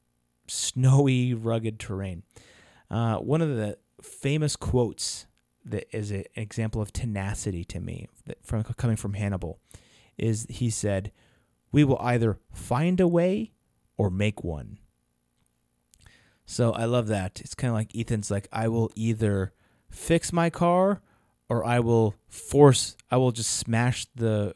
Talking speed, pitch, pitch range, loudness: 145 wpm, 110 Hz, 100-120 Hz, -26 LUFS